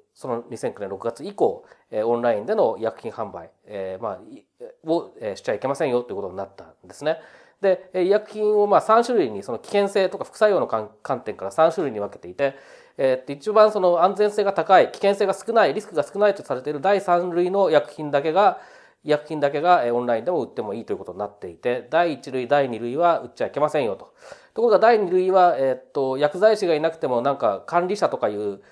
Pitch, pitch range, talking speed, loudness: 175 Hz, 135-210 Hz, 410 characters per minute, -22 LUFS